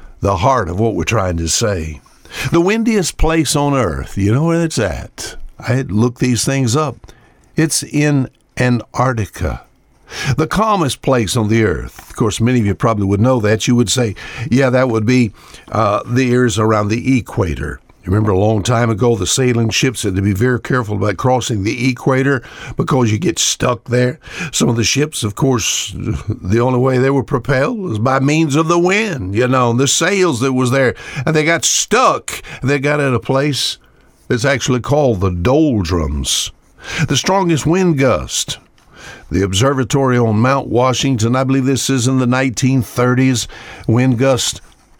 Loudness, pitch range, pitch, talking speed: -15 LUFS, 110-135 Hz, 125 Hz, 180 wpm